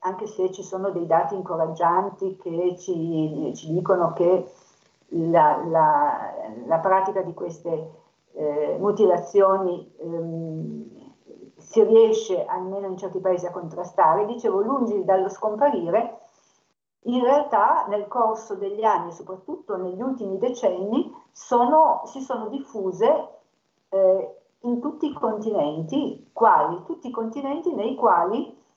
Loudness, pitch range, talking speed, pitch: -23 LUFS, 175-245 Hz, 120 wpm, 195 Hz